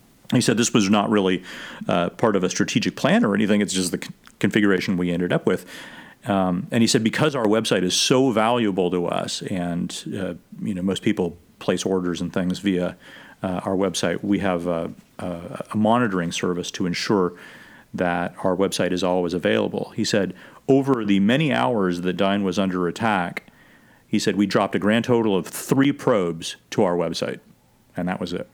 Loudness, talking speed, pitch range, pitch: -22 LUFS, 195 wpm, 90-105 Hz, 95 Hz